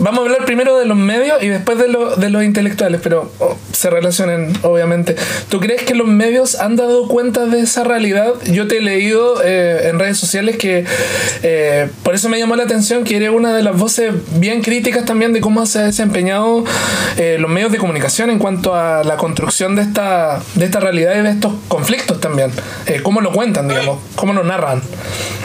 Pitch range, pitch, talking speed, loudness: 175-230 Hz, 205 Hz, 205 wpm, -14 LUFS